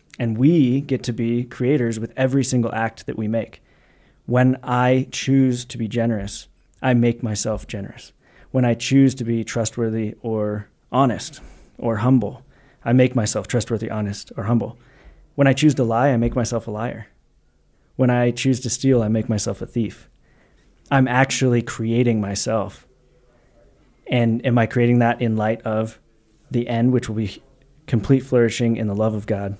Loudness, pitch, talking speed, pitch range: -20 LUFS, 120 Hz, 170 wpm, 110-125 Hz